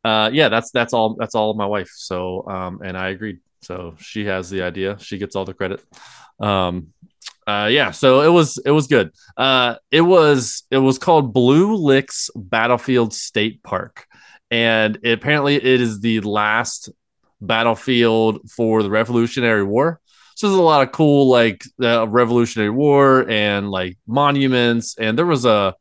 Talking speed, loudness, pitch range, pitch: 175 wpm, -17 LUFS, 105-130 Hz, 115 Hz